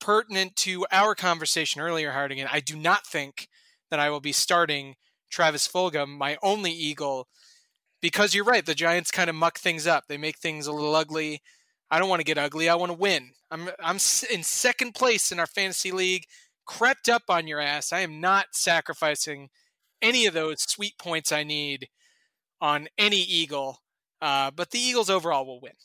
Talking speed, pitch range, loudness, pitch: 190 wpm, 150-195 Hz, -25 LUFS, 170 Hz